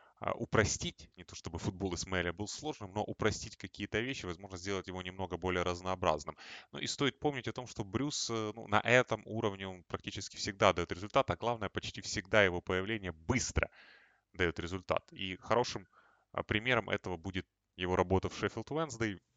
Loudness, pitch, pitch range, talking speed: -35 LUFS, 100 Hz, 90-110 Hz, 170 wpm